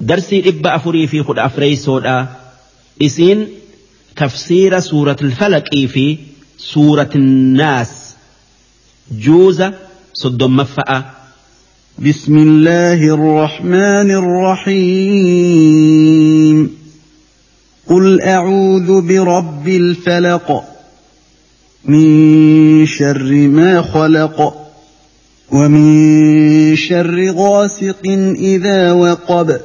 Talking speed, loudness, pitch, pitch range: 70 wpm, -10 LUFS, 155 Hz, 145-180 Hz